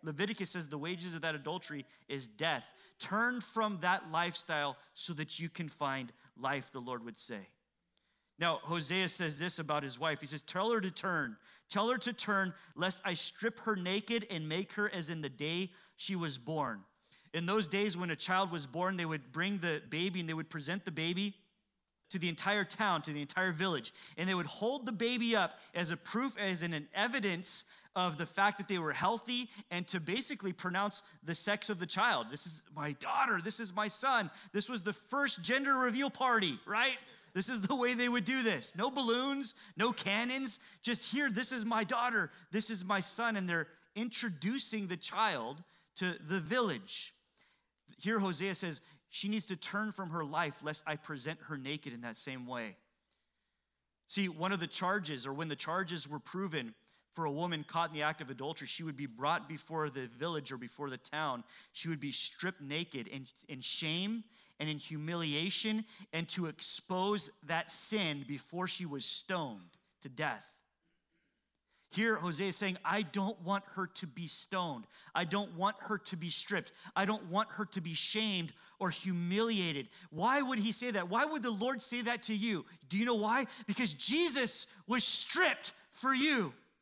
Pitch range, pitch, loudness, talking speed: 160-215 Hz, 185 Hz, -35 LUFS, 195 wpm